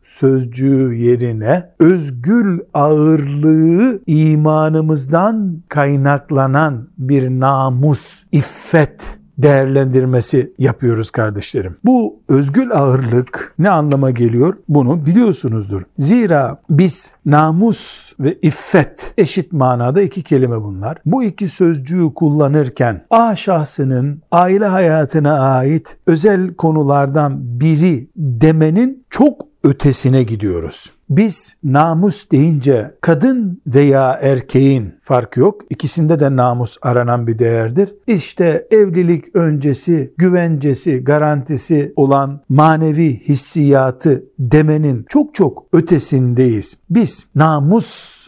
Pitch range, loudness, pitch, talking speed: 135-175 Hz, -14 LUFS, 150 Hz, 90 wpm